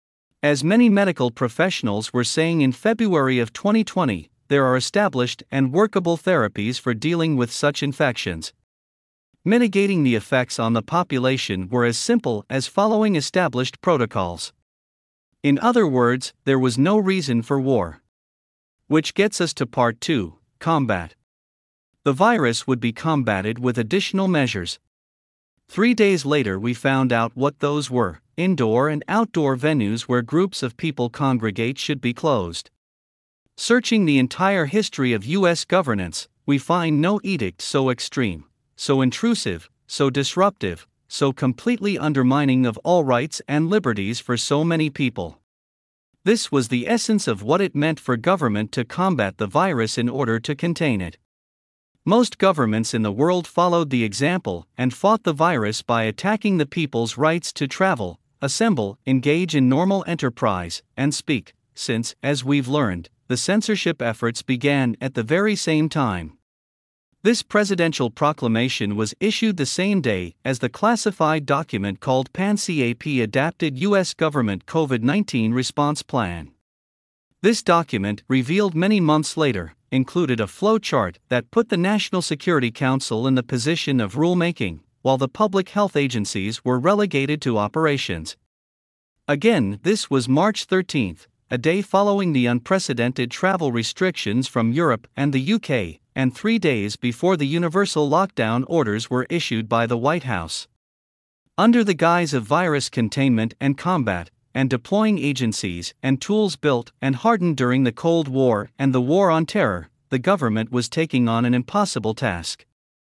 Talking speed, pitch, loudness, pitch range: 150 wpm, 135 Hz, -21 LUFS, 115-170 Hz